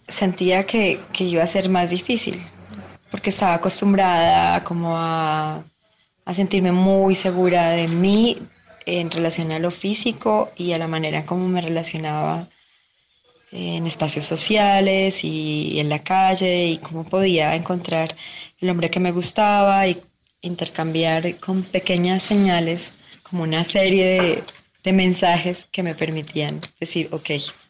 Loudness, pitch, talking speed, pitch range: -20 LUFS, 175 Hz, 135 wpm, 160-190 Hz